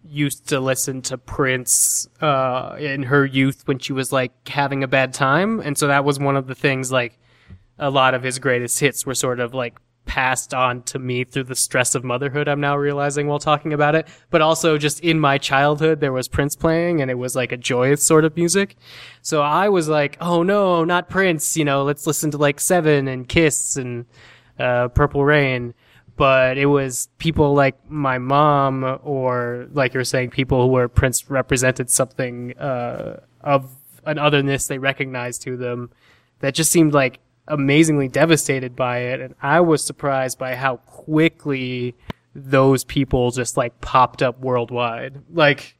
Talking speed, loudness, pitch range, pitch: 185 wpm, -19 LUFS, 130-150 Hz, 135 Hz